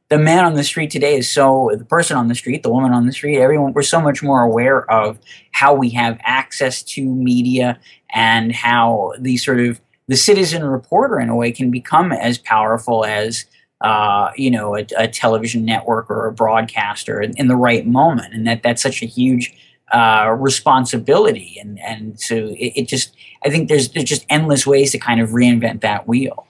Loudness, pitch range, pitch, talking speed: -15 LUFS, 115-135 Hz, 120 Hz, 200 wpm